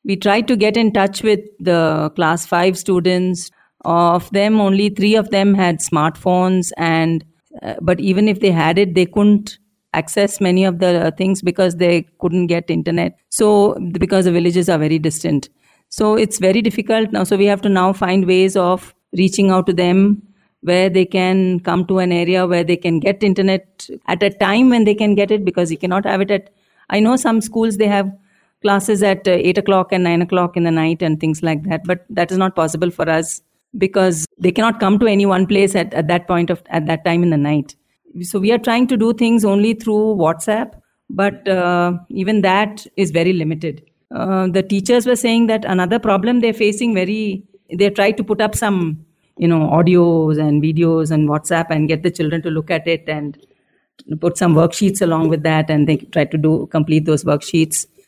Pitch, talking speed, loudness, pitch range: 185 Hz, 205 wpm, -16 LUFS, 170-200 Hz